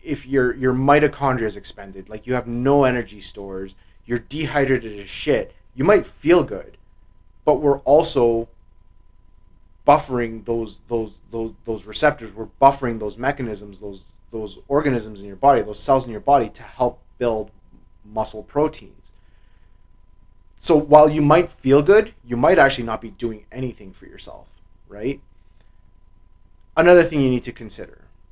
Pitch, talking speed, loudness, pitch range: 115 Hz, 150 wpm, -19 LUFS, 100-135 Hz